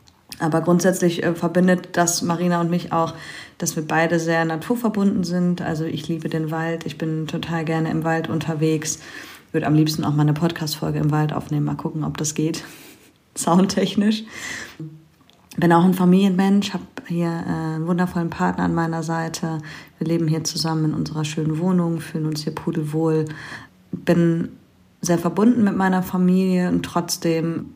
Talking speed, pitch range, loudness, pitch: 160 wpm, 160-175 Hz, -21 LUFS, 165 Hz